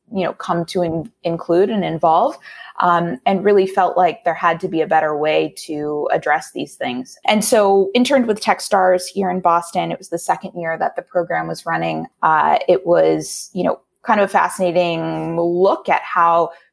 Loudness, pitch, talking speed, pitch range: -17 LUFS, 175 Hz, 195 wpm, 165-195 Hz